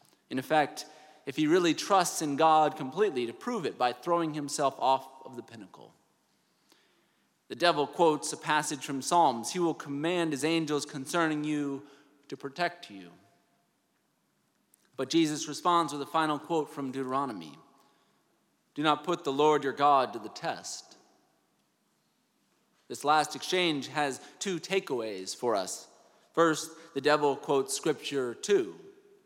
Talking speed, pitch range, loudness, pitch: 140 wpm, 140-170 Hz, -29 LUFS, 150 Hz